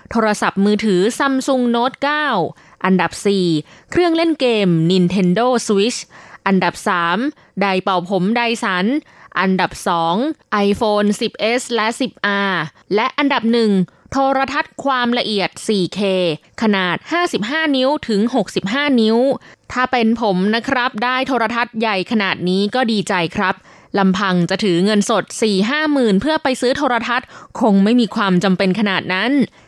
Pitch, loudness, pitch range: 215 Hz, -17 LUFS, 190-250 Hz